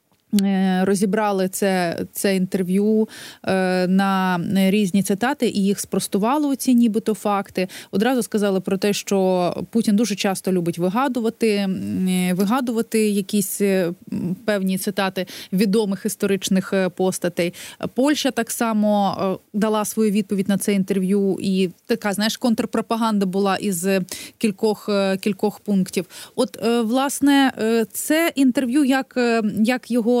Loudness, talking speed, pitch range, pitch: -21 LUFS, 110 wpm, 190-230 Hz, 205 Hz